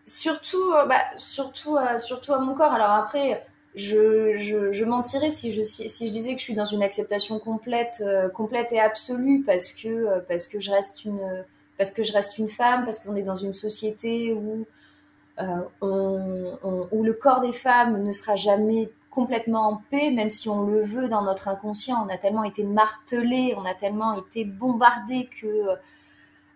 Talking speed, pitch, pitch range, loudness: 190 wpm, 220 Hz, 200-240 Hz, -24 LUFS